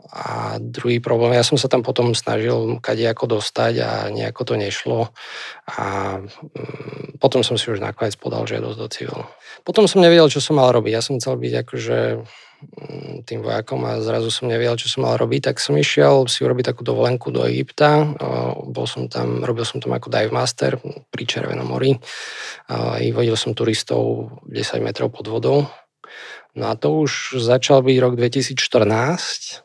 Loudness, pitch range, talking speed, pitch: -19 LUFS, 100-135 Hz, 175 wpm, 120 Hz